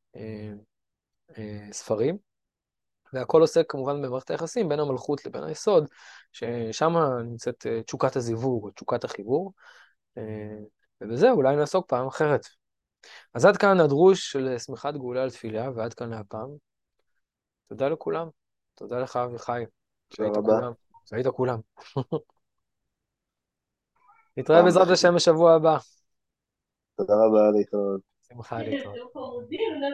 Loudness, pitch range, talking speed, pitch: -24 LUFS, 115-160 Hz, 100 wpm, 130 Hz